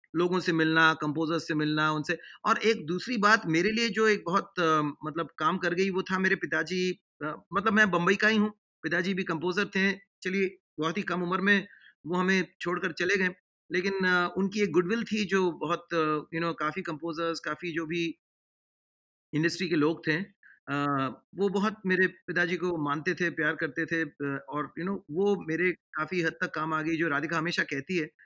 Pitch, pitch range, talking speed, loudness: 175 Hz, 160-190 Hz, 190 wpm, -28 LUFS